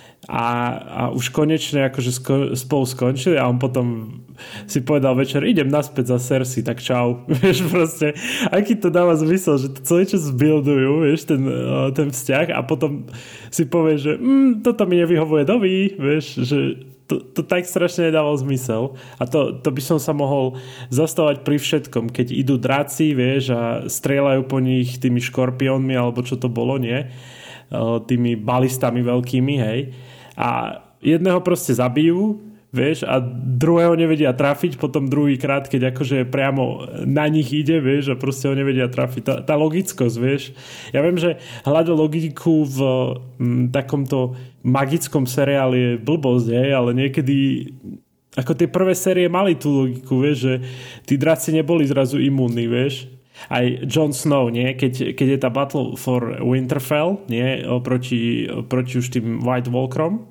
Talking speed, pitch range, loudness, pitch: 155 wpm, 125-155 Hz, -19 LUFS, 135 Hz